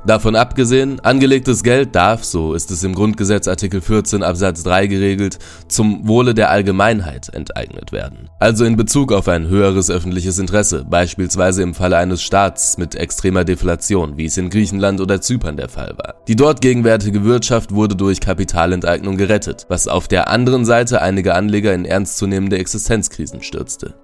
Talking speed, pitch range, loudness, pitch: 160 wpm, 90-110 Hz, -15 LUFS, 100 Hz